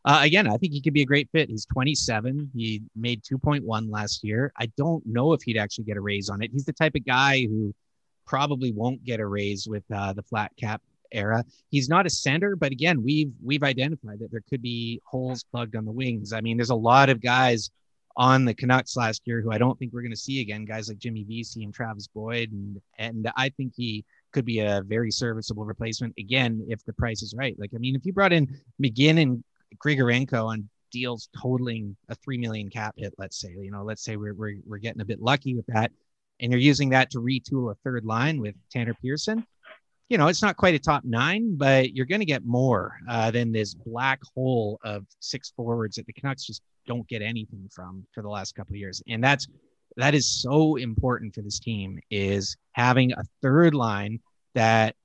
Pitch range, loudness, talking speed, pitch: 110-135 Hz, -25 LUFS, 220 wpm, 120 Hz